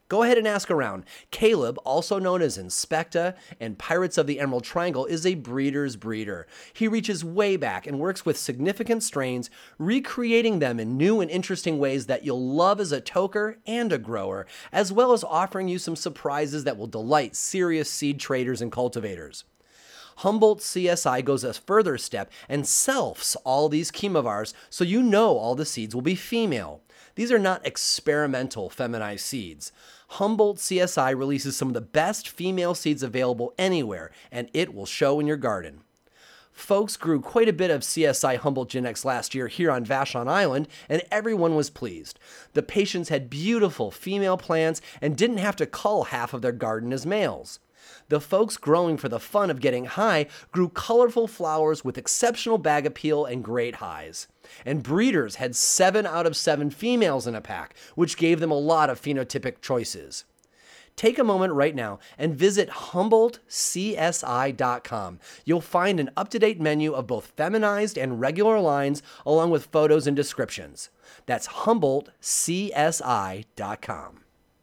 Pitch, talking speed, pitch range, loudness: 160 Hz, 165 wpm, 135-200 Hz, -25 LUFS